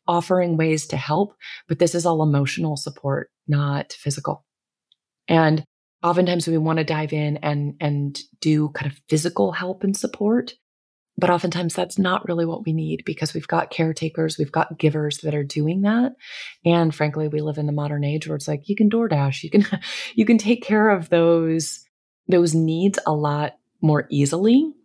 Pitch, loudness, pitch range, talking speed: 160 Hz, -21 LUFS, 150-180 Hz, 180 wpm